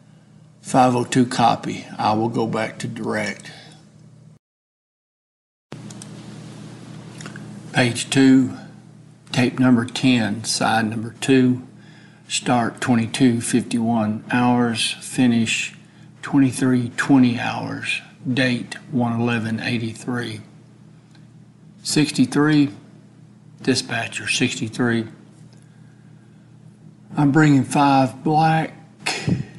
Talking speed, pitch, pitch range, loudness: 65 wpm, 135 Hz, 120-160 Hz, -20 LUFS